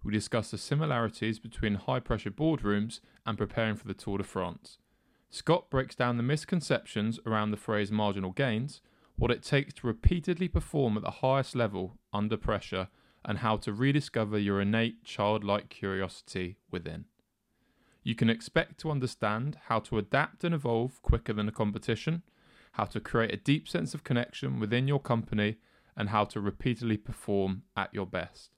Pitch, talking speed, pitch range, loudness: 110 Hz, 165 wpm, 105-130 Hz, -32 LUFS